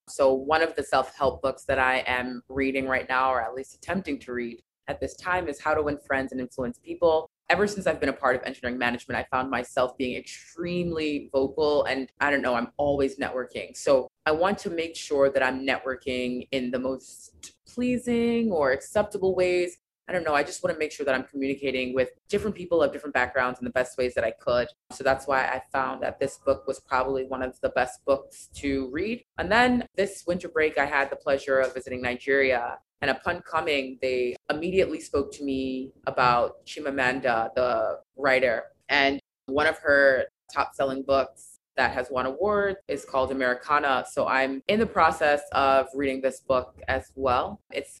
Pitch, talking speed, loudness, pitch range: 135 Hz, 200 wpm, -26 LUFS, 130-155 Hz